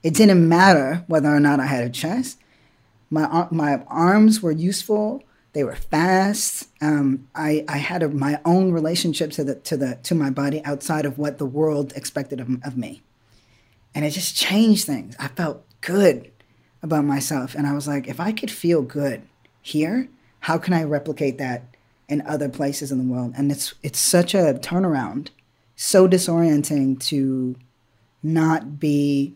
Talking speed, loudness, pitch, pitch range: 170 wpm, -21 LUFS, 150 Hz, 135-165 Hz